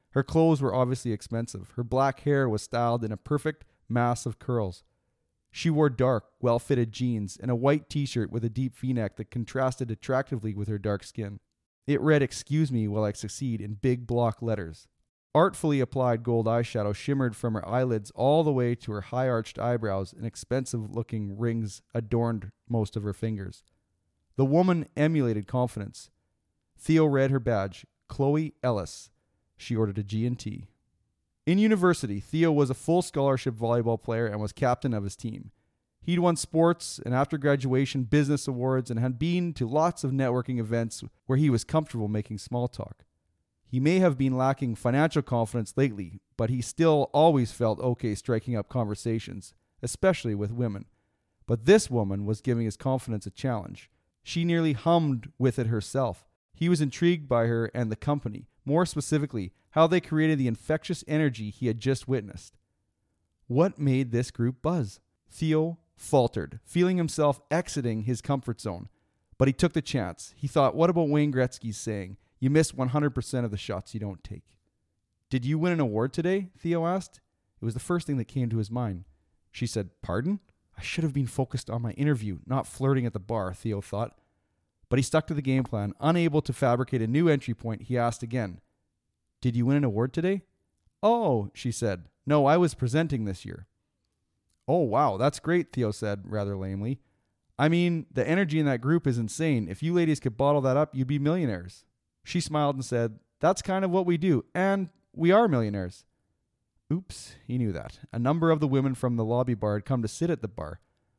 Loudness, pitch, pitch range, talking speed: -27 LUFS, 125 Hz, 110-145 Hz, 185 wpm